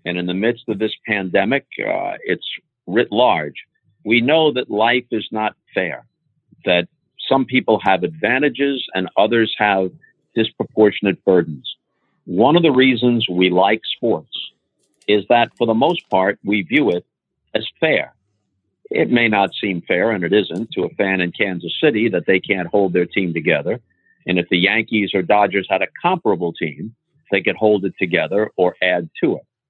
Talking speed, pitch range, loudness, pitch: 175 wpm, 90-115 Hz, -18 LUFS, 105 Hz